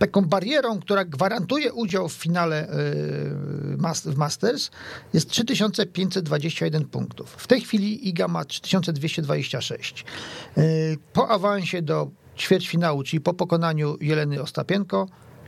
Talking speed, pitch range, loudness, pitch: 105 wpm, 150-195 Hz, -24 LUFS, 170 Hz